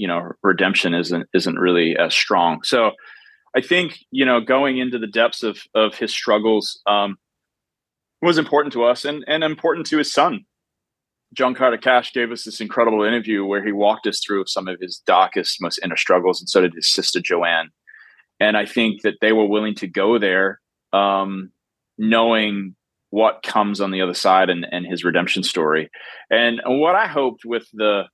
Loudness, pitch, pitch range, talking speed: -19 LUFS, 105 Hz, 95-120 Hz, 185 wpm